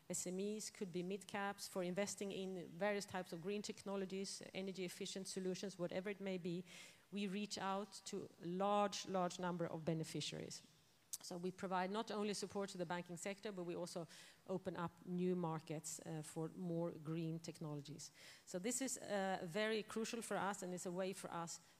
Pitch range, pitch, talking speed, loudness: 175-200 Hz, 185 Hz, 180 wpm, -46 LUFS